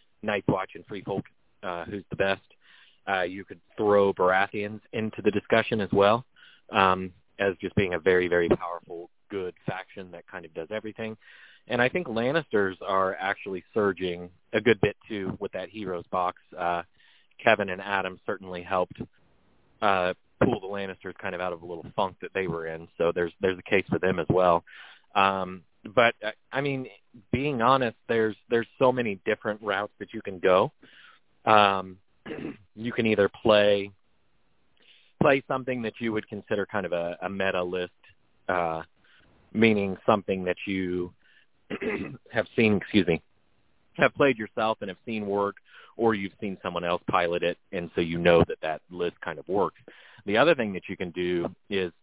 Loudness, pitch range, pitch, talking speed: -27 LUFS, 90-110 Hz, 95 Hz, 175 wpm